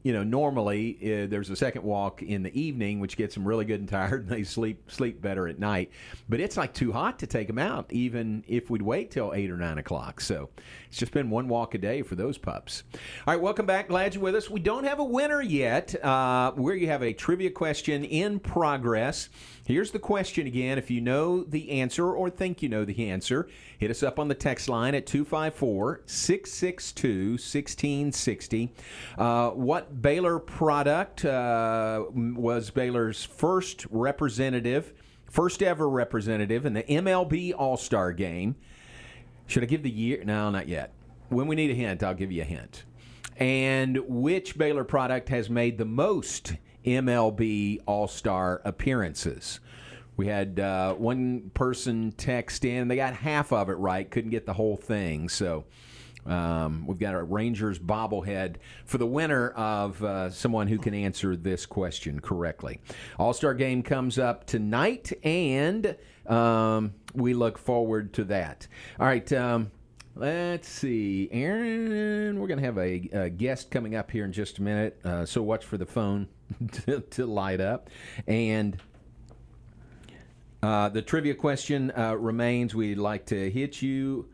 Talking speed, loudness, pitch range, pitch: 170 wpm, -28 LUFS, 105-140 Hz, 120 Hz